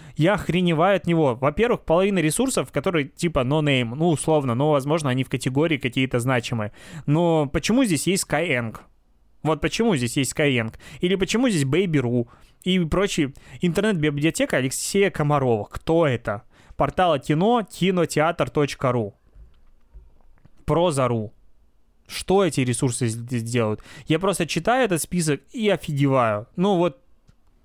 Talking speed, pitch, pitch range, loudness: 130 wpm, 150 Hz, 125-175 Hz, -22 LUFS